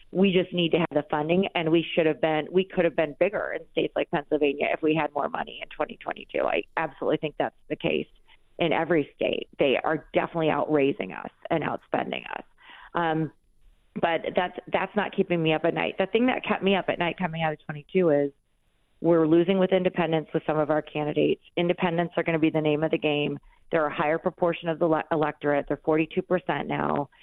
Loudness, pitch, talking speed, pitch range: -26 LUFS, 165 Hz, 220 wpm, 150-180 Hz